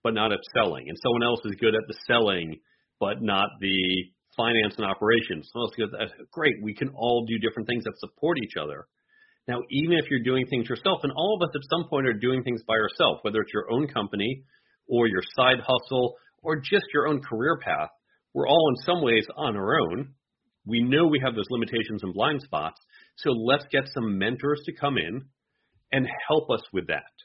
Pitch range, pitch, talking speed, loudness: 115-145 Hz, 125 Hz, 215 wpm, -26 LUFS